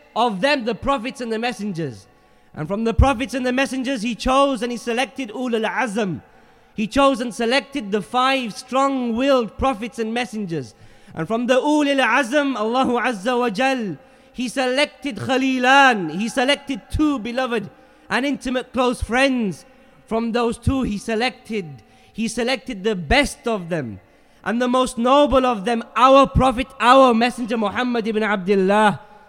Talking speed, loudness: 155 wpm, -20 LUFS